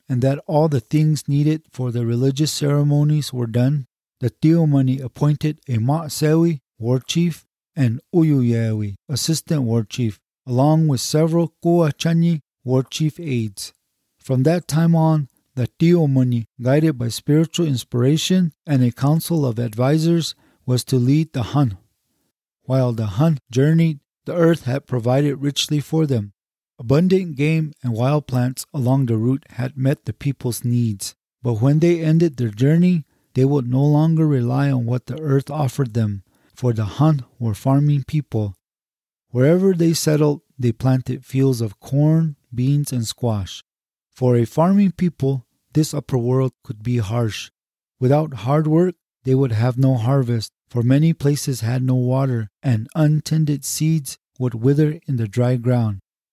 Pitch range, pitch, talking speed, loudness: 125-155 Hz, 135 Hz, 150 wpm, -19 LUFS